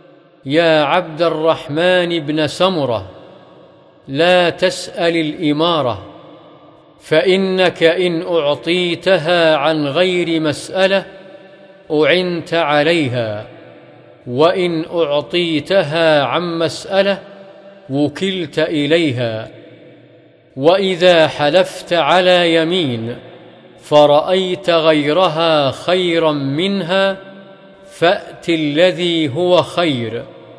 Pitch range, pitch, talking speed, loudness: 155-180 Hz, 170 Hz, 65 wpm, -15 LUFS